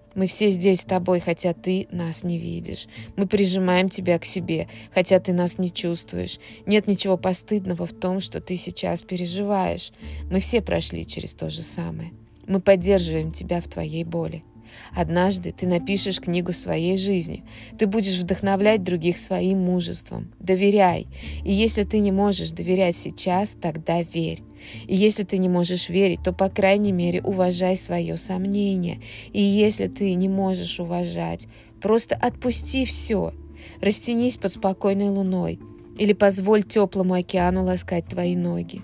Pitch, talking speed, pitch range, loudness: 180 Hz, 150 wpm, 165-195 Hz, -23 LUFS